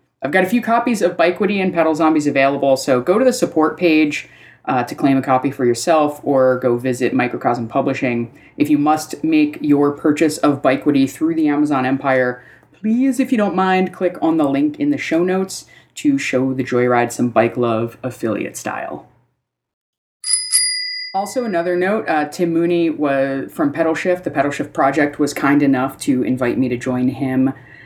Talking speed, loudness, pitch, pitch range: 185 wpm, -17 LUFS, 150 Hz, 135-185 Hz